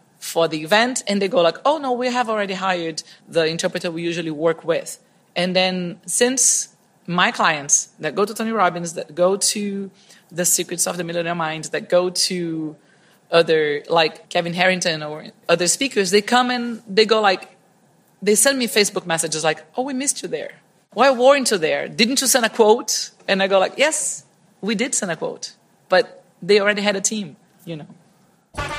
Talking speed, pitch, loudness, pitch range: 190 wpm, 195 Hz, -19 LUFS, 170-220 Hz